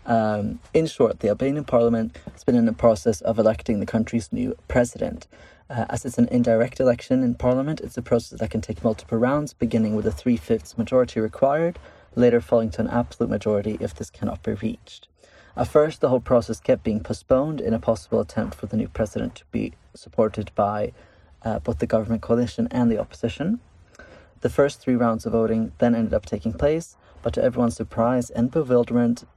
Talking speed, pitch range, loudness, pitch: 195 wpm, 110-125 Hz, -23 LUFS, 115 Hz